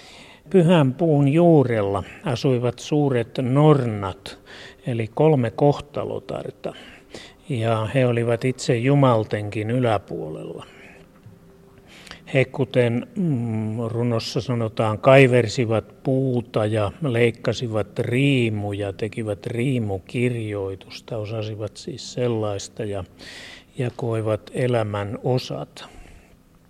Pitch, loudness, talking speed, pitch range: 120 Hz, -22 LUFS, 75 wpm, 105-130 Hz